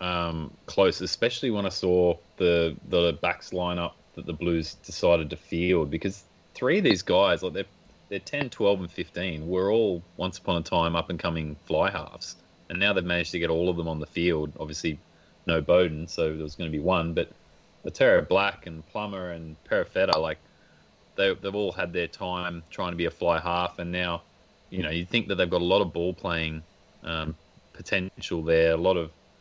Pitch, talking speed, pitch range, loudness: 85 Hz, 205 wpm, 80-90 Hz, -27 LUFS